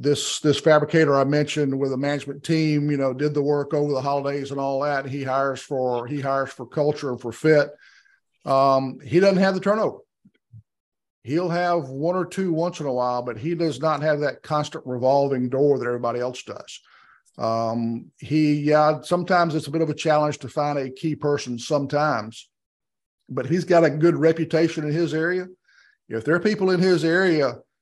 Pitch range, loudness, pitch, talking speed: 135-160 Hz, -22 LUFS, 145 Hz, 195 wpm